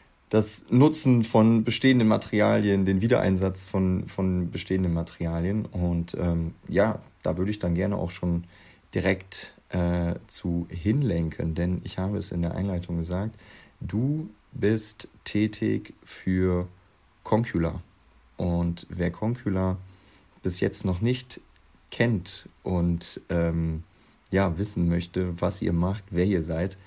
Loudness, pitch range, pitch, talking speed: -26 LUFS, 85-105 Hz, 95 Hz, 125 wpm